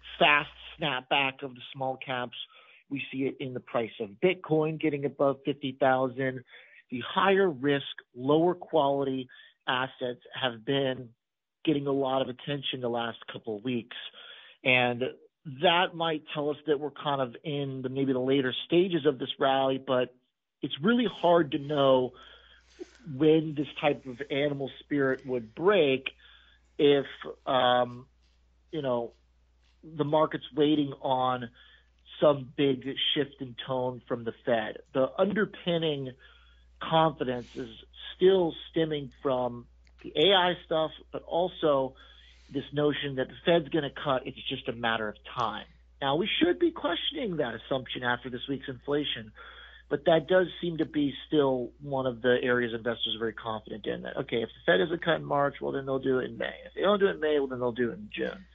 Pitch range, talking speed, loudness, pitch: 125-150 Hz, 170 wpm, -29 LUFS, 135 Hz